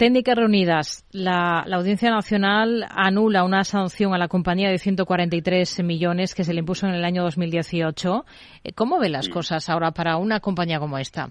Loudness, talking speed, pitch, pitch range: -22 LUFS, 175 wpm, 180 Hz, 170-195 Hz